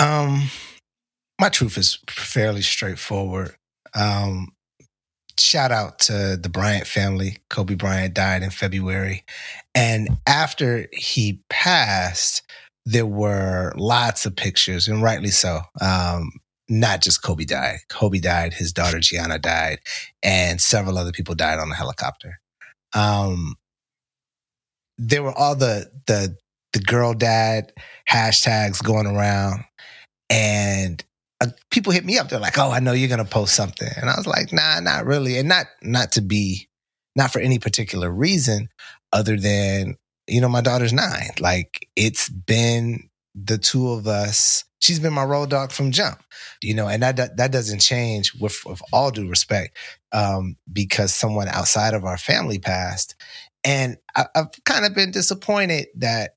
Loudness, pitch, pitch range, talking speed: -20 LUFS, 105 Hz, 95-125 Hz, 150 wpm